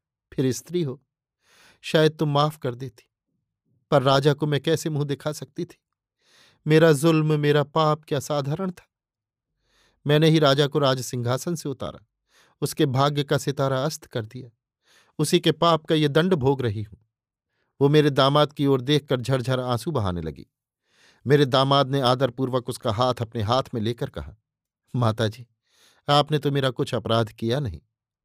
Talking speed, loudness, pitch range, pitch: 165 wpm, -23 LUFS, 120-150 Hz, 135 Hz